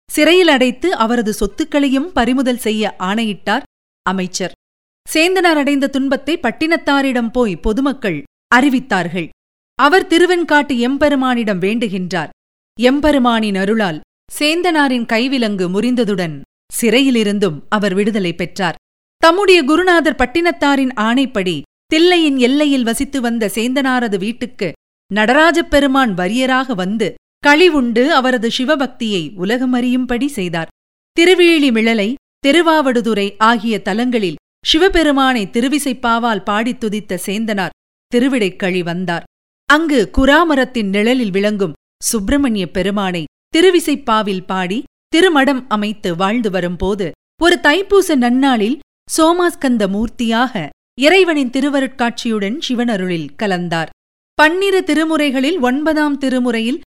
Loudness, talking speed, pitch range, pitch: -14 LUFS, 85 wpm, 210-290 Hz, 245 Hz